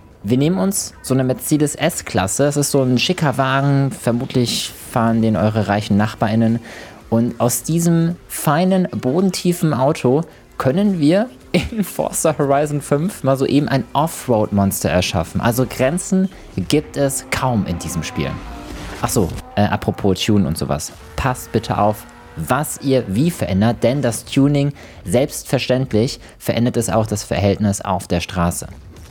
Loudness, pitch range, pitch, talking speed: -18 LUFS, 105-145 Hz, 125 Hz, 140 wpm